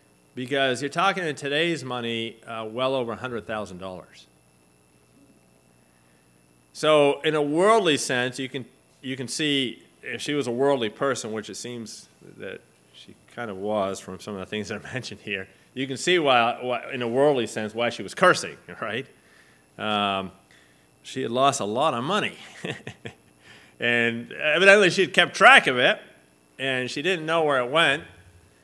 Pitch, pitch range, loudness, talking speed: 115 Hz, 90-140 Hz, -23 LUFS, 165 wpm